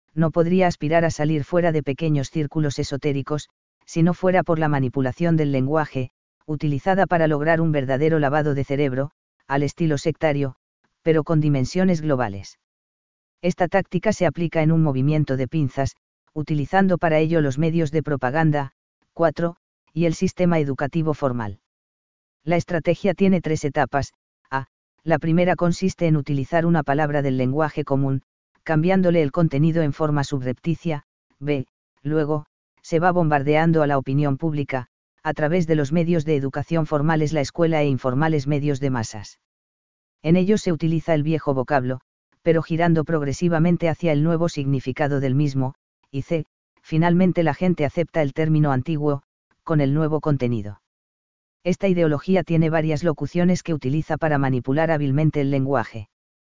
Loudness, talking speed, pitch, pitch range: -22 LUFS, 150 wpm, 155 Hz, 140-165 Hz